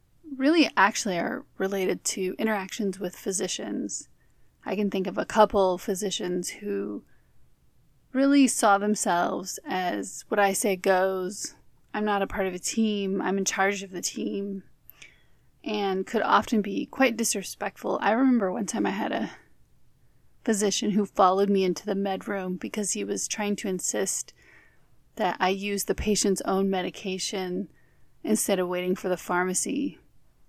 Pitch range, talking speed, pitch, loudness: 185-210 Hz, 150 wpm, 200 Hz, -26 LUFS